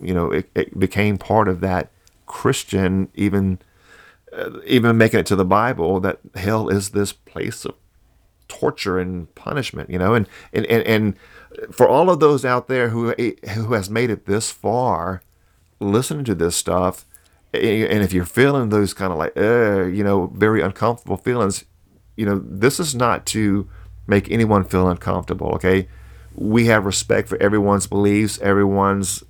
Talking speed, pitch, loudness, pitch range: 165 wpm, 100 Hz, -19 LUFS, 95-110 Hz